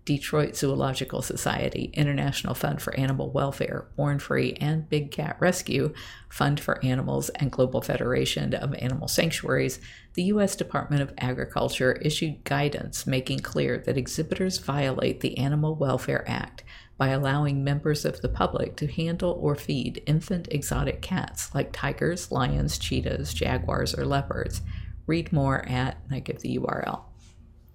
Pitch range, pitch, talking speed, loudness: 125-150 Hz, 140 Hz, 145 wpm, -27 LUFS